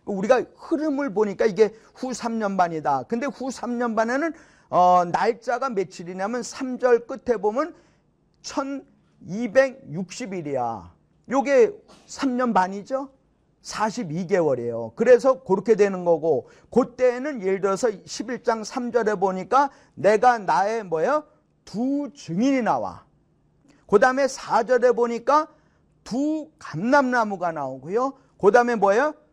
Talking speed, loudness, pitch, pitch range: 230 characters per minute, -23 LUFS, 240 Hz, 195-265 Hz